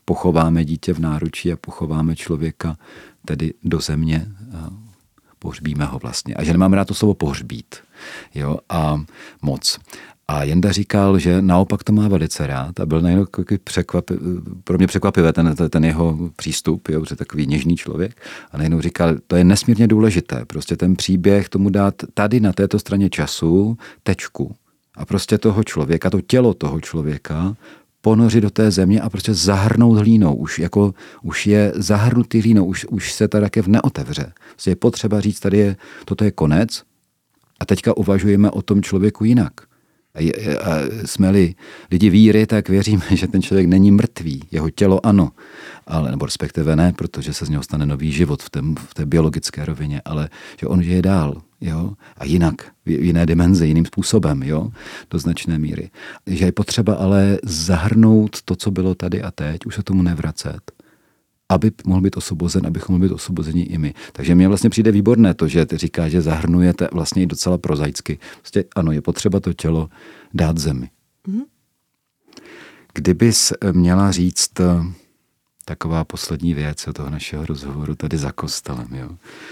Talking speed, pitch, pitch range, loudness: 170 wpm, 90 Hz, 80-100 Hz, -18 LUFS